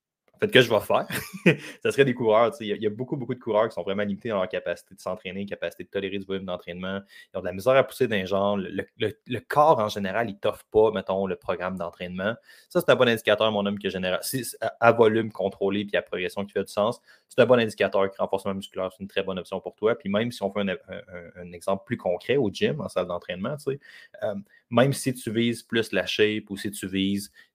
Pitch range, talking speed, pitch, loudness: 95-115 Hz, 255 wpm, 100 Hz, -26 LUFS